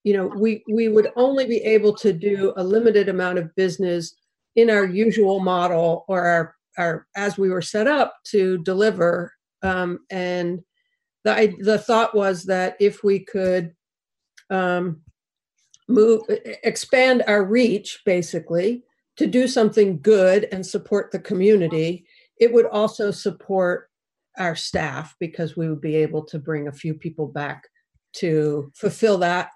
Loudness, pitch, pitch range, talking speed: -21 LUFS, 195 Hz, 175-215 Hz, 150 wpm